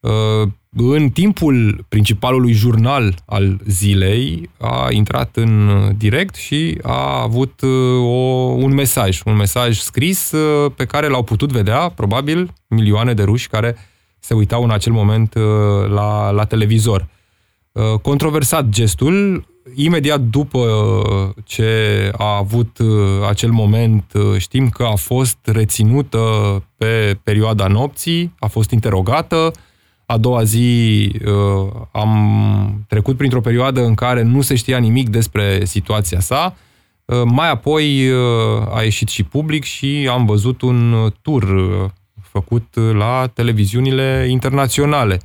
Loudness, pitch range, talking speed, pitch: -15 LUFS, 105-130 Hz, 115 wpm, 115 Hz